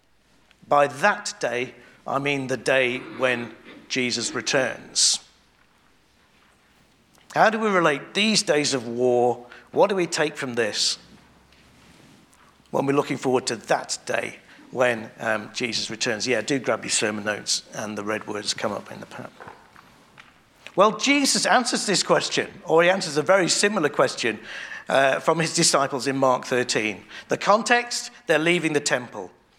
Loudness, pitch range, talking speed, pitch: -22 LUFS, 125-185 Hz, 155 wpm, 145 Hz